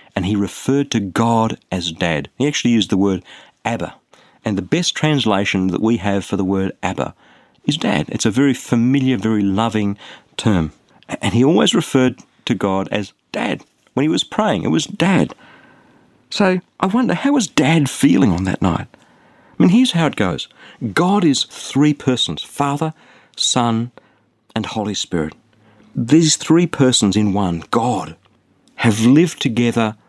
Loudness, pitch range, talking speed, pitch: -17 LUFS, 100-145 Hz, 165 wpm, 115 Hz